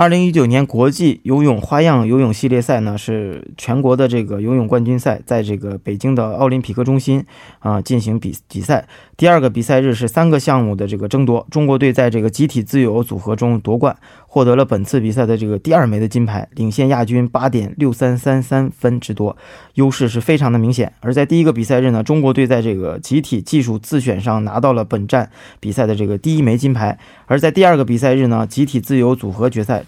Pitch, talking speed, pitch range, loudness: 125 Hz, 340 characters per minute, 110-135 Hz, -15 LUFS